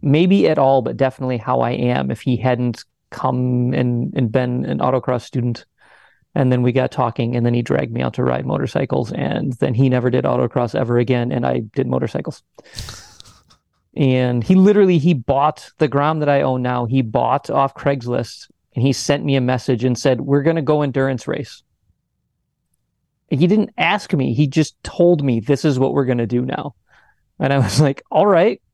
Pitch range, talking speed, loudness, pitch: 125-140 Hz, 195 wpm, -18 LUFS, 130 Hz